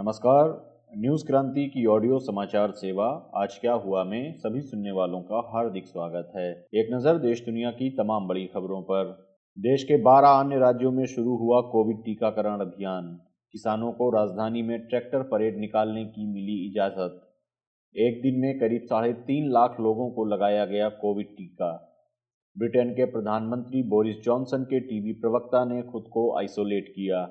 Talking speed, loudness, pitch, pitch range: 165 wpm, -26 LUFS, 110 Hz, 105-125 Hz